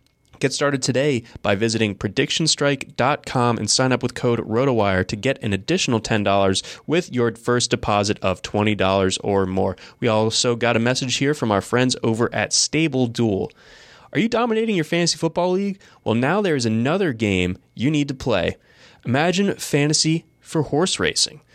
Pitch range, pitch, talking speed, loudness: 110-150 Hz, 125 Hz, 165 wpm, -20 LUFS